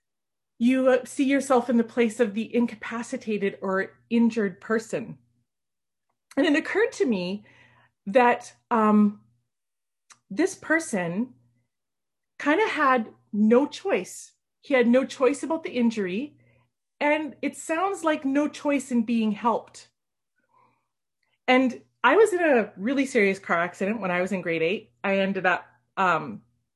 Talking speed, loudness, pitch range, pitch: 135 wpm, -24 LUFS, 195-280 Hz, 235 Hz